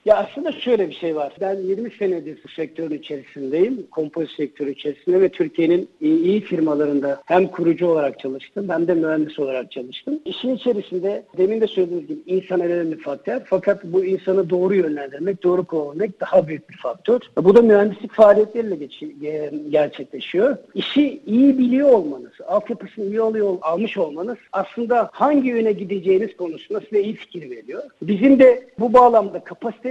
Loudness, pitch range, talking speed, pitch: -19 LUFS, 160-230 Hz, 155 wpm, 190 Hz